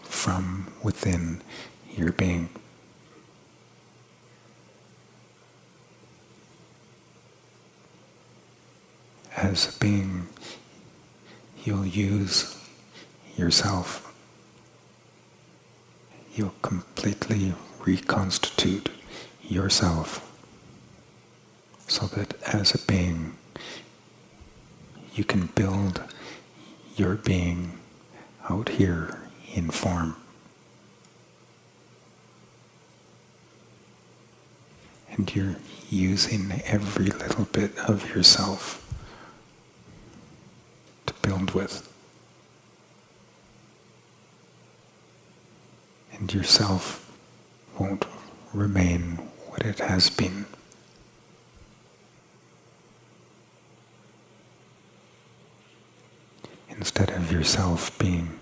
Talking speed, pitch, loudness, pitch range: 50 wpm, 95 Hz, -26 LUFS, 85-100 Hz